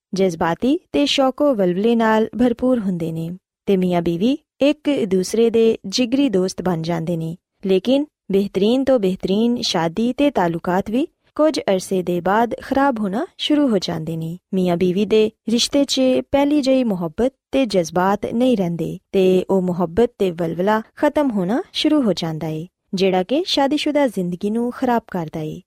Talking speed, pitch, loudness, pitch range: 160 wpm, 210 Hz, -19 LUFS, 185-265 Hz